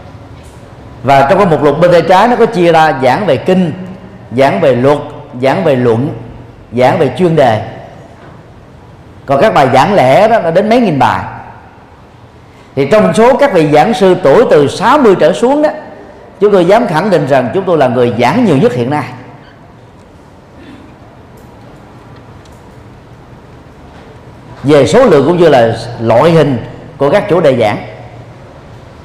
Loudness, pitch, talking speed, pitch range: -9 LUFS, 145 Hz, 160 wpm, 125-185 Hz